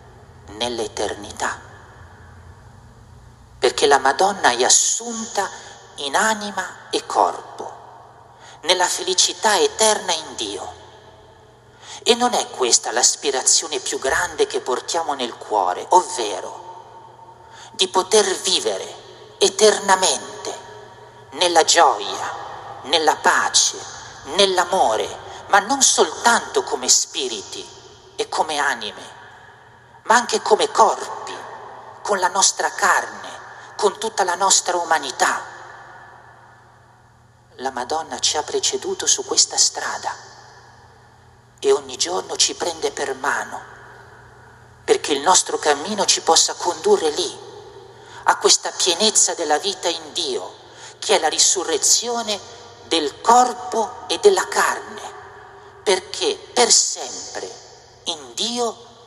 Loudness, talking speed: -18 LUFS, 105 wpm